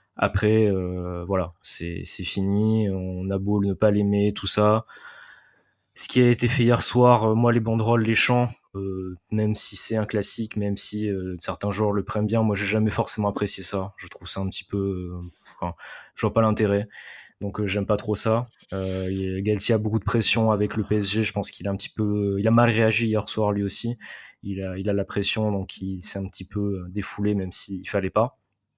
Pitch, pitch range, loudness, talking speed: 105 Hz, 95-110 Hz, -22 LUFS, 225 wpm